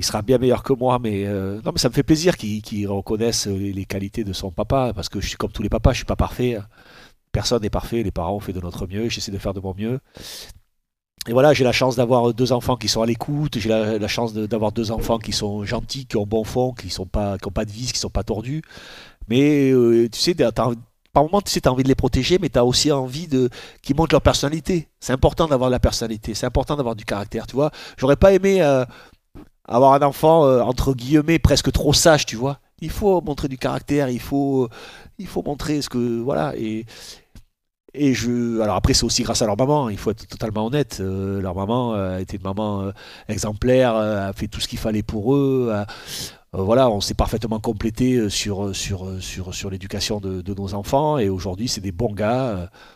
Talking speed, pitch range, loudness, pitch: 230 wpm, 105-135 Hz, -21 LUFS, 115 Hz